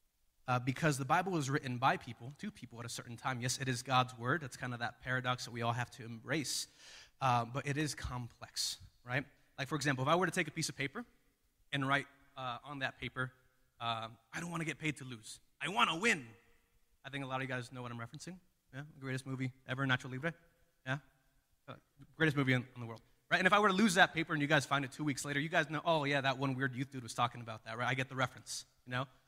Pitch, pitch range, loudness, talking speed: 130 Hz, 125-150 Hz, -36 LUFS, 265 wpm